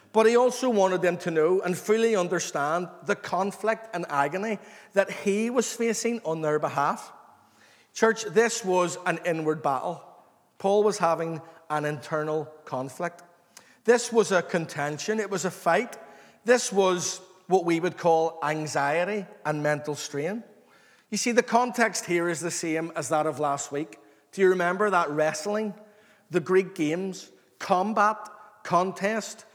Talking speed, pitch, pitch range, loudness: 150 wpm, 180 Hz, 160-210 Hz, -26 LUFS